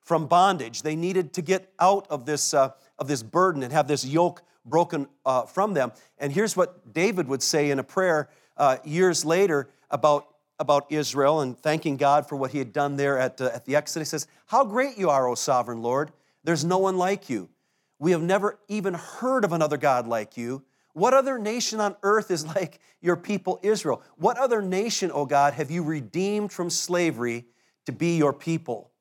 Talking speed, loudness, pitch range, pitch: 205 wpm, -25 LUFS, 140-185 Hz, 155 Hz